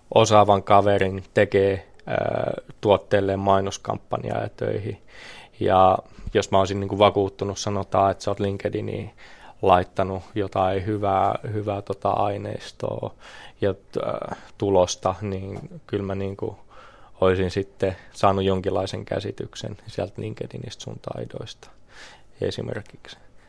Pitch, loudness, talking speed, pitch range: 100 Hz, -24 LUFS, 100 wpm, 95-100 Hz